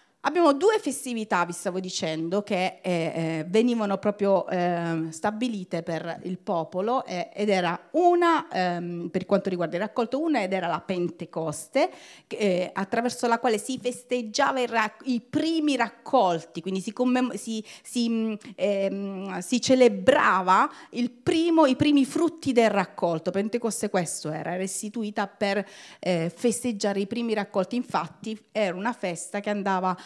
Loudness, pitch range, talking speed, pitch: -26 LUFS, 185-245 Hz, 145 wpm, 205 Hz